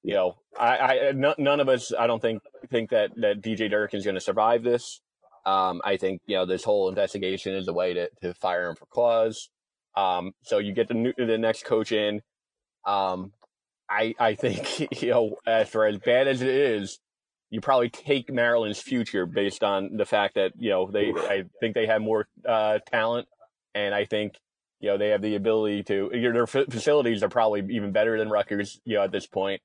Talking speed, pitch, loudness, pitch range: 210 wpm, 110 Hz, -25 LUFS, 100-120 Hz